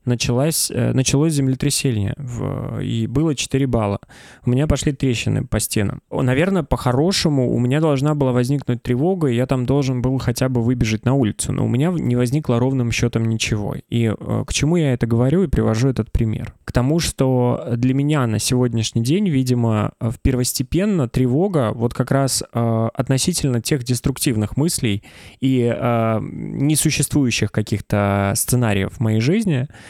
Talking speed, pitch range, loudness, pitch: 150 wpm, 115-140 Hz, -19 LUFS, 130 Hz